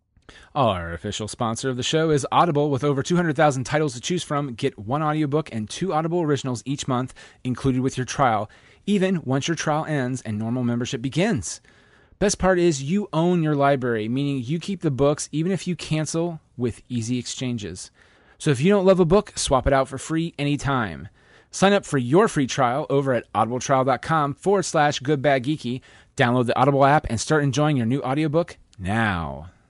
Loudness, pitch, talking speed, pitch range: -22 LUFS, 140 Hz, 195 wpm, 125-155 Hz